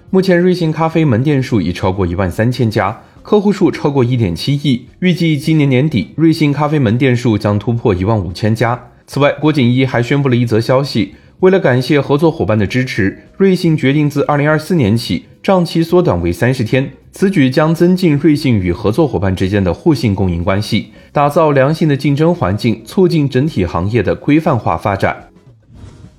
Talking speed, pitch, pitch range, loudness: 305 characters per minute, 130 Hz, 110-155 Hz, -13 LUFS